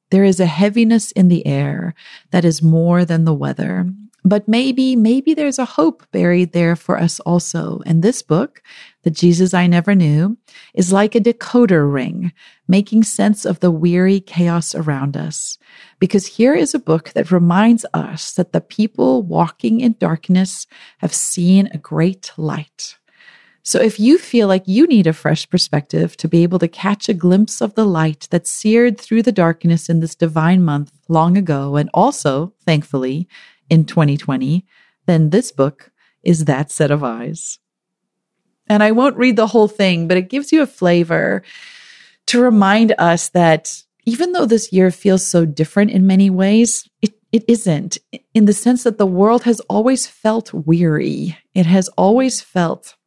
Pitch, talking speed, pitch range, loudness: 185 Hz, 170 wpm, 165-220 Hz, -15 LUFS